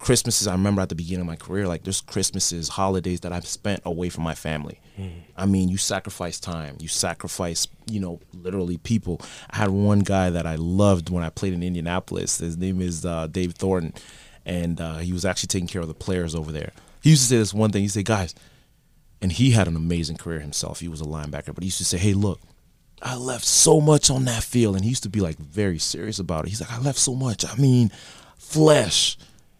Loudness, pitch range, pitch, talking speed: -23 LUFS, 85-105 Hz, 95 Hz, 235 wpm